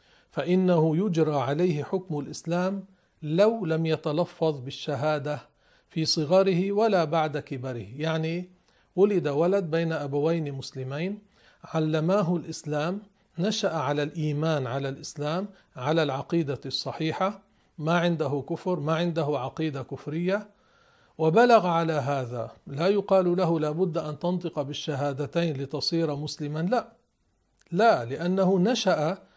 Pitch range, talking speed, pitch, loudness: 150-185 Hz, 110 wpm, 160 Hz, -27 LUFS